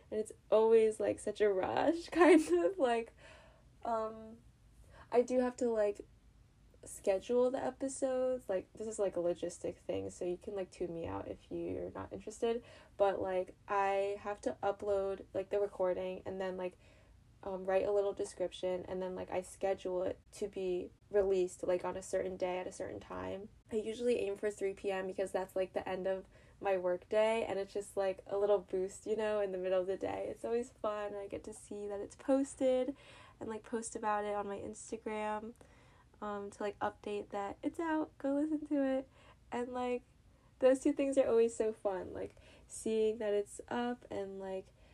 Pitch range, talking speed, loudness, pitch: 190-230 Hz, 195 wpm, -36 LUFS, 205 Hz